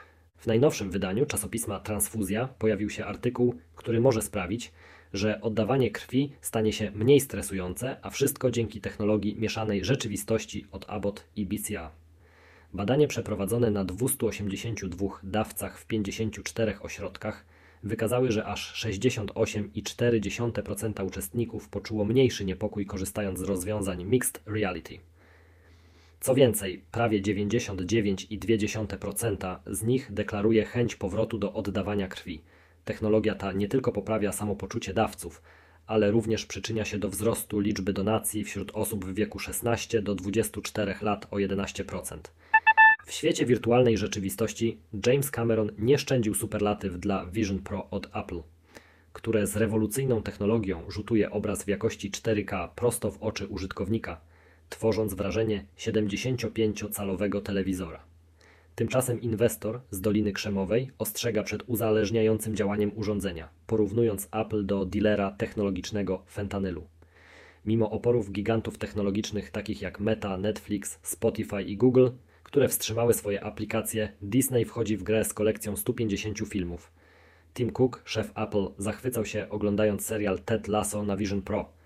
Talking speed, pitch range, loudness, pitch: 125 wpm, 100-110 Hz, -28 LUFS, 105 Hz